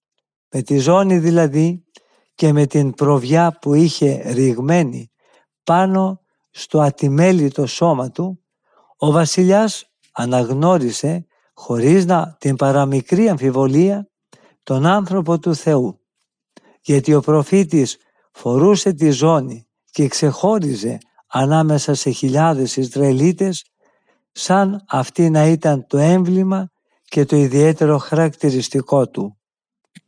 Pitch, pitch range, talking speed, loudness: 155 Hz, 140-175 Hz, 100 wpm, -16 LUFS